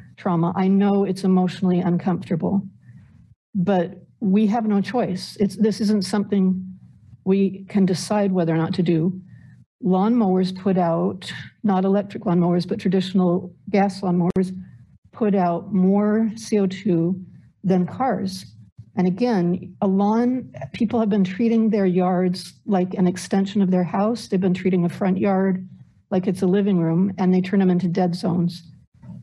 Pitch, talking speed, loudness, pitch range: 190 Hz, 150 wpm, -21 LUFS, 180-200 Hz